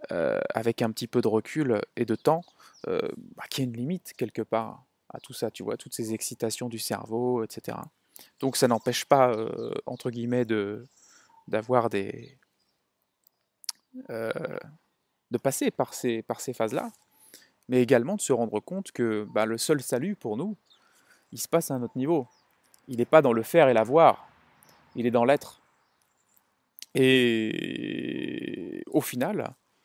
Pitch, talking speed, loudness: 125 Hz, 165 wpm, -27 LUFS